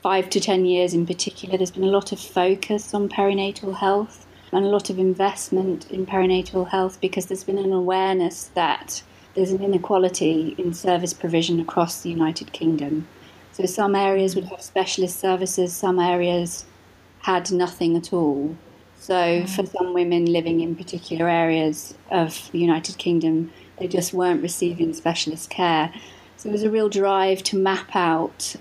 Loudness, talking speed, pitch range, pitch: -22 LUFS, 165 wpm, 170-190 Hz, 185 Hz